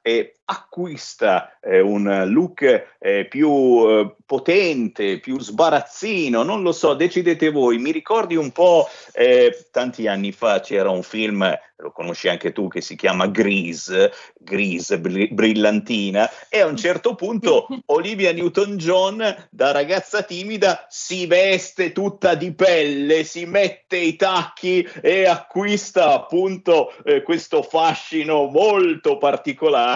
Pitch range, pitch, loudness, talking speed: 155-245 Hz, 180 Hz, -19 LUFS, 130 wpm